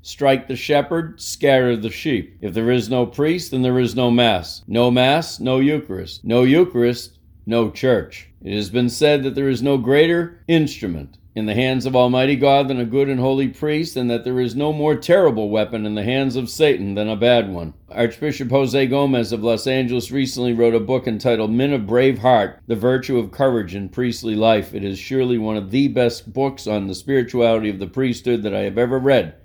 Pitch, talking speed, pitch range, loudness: 125 Hz, 210 wpm, 110-135 Hz, -19 LUFS